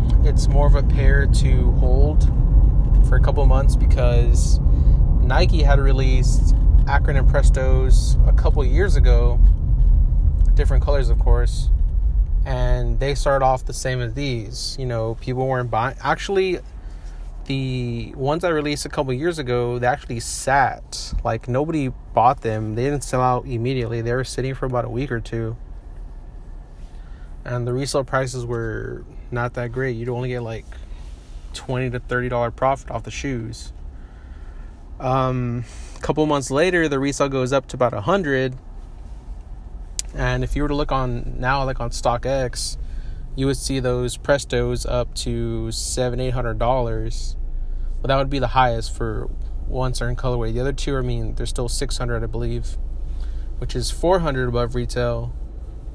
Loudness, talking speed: -21 LUFS, 160 wpm